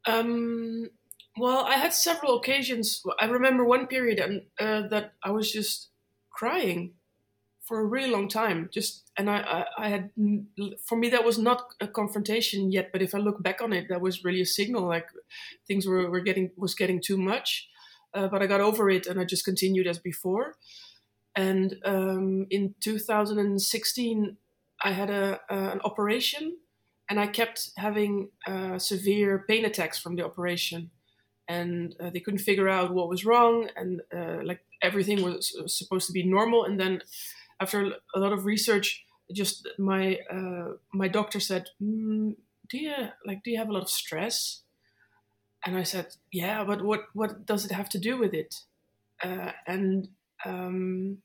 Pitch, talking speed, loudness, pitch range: 200 Hz, 180 wpm, -28 LUFS, 185-215 Hz